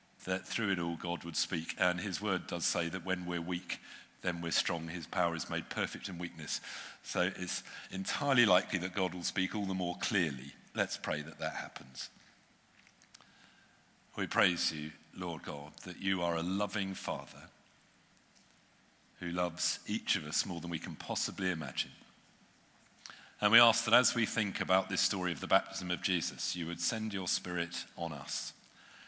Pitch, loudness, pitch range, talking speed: 90 Hz, -34 LUFS, 85-95 Hz, 180 wpm